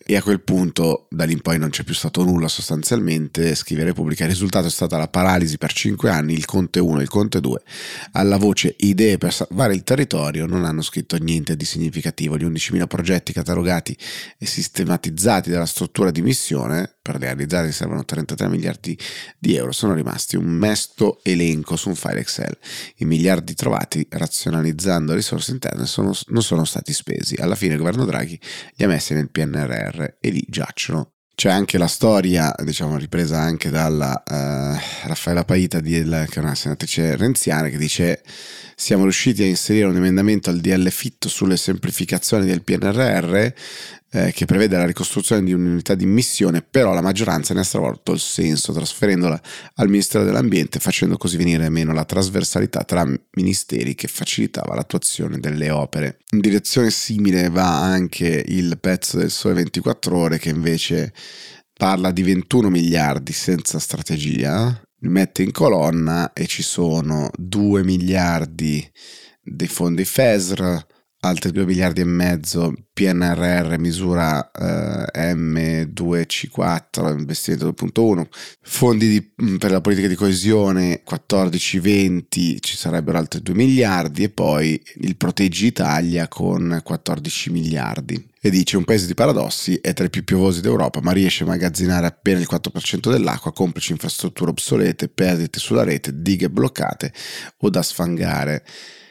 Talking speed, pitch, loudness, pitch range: 155 wpm, 90 Hz, -19 LUFS, 80-95 Hz